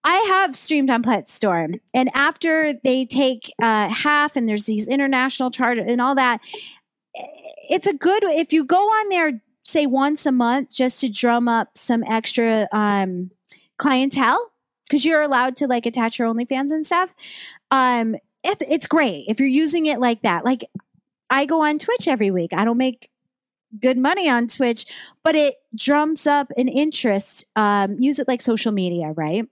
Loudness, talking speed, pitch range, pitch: -19 LUFS, 175 wpm, 230-295 Hz, 255 Hz